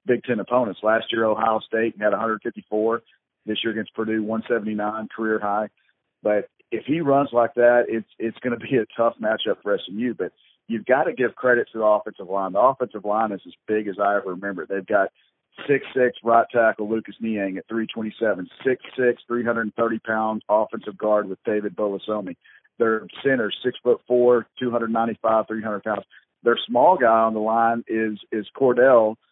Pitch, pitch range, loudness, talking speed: 110 Hz, 105-115 Hz, -22 LUFS, 195 wpm